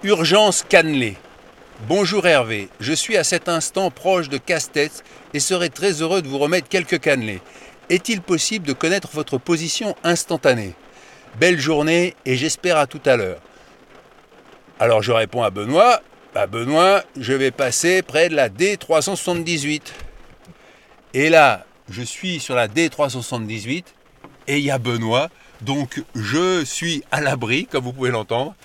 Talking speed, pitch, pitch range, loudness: 150 wpm, 160 Hz, 135-180 Hz, -19 LUFS